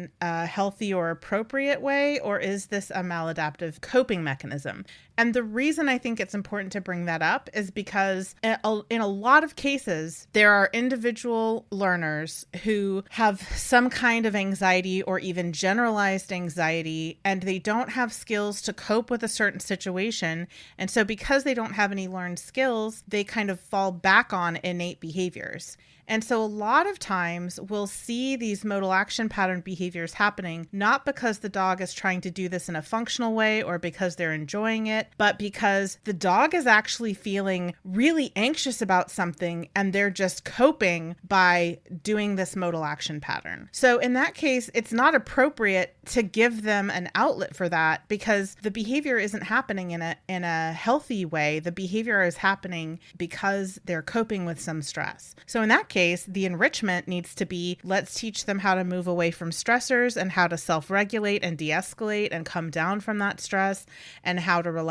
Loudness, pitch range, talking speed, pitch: -26 LUFS, 180-225 Hz, 180 wpm, 195 Hz